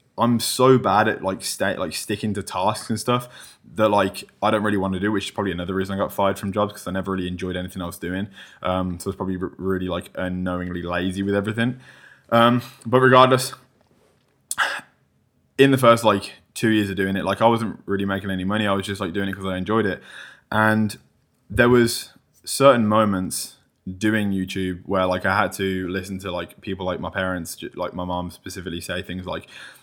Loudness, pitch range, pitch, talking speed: -22 LUFS, 95-110 Hz, 100 Hz, 210 wpm